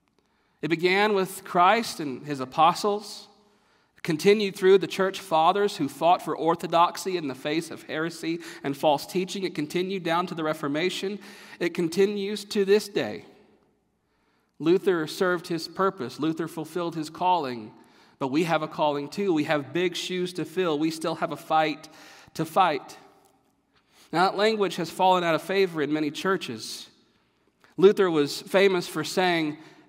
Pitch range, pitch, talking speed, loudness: 155-195 Hz, 175 Hz, 155 wpm, -25 LUFS